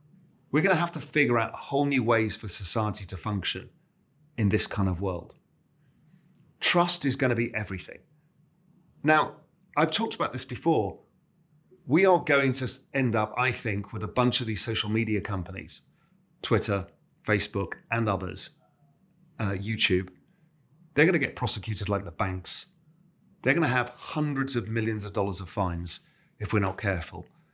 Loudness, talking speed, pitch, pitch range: -27 LUFS, 165 wpm, 125 Hz, 105-155 Hz